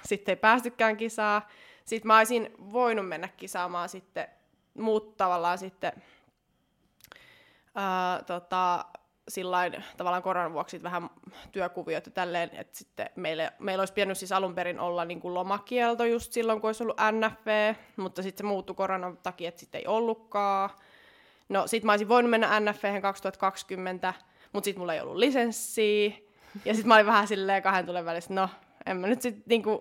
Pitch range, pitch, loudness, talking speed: 185-220 Hz, 195 Hz, -28 LUFS, 165 wpm